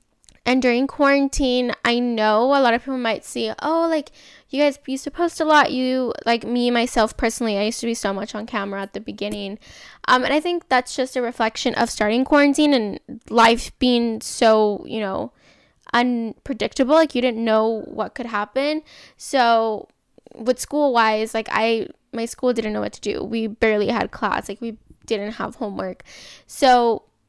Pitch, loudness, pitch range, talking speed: 240 Hz, -20 LUFS, 220-270 Hz, 185 wpm